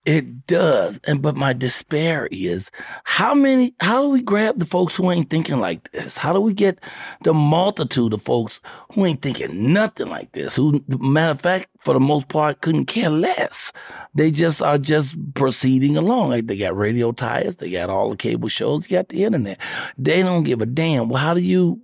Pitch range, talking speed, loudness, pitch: 135-180 Hz, 205 wpm, -19 LUFS, 155 Hz